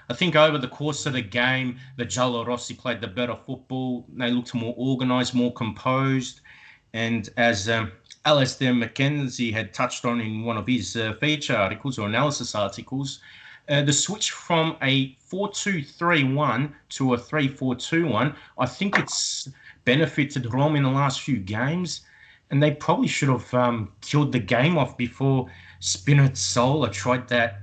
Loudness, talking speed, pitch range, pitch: -24 LUFS, 160 wpm, 120-145 Hz, 130 Hz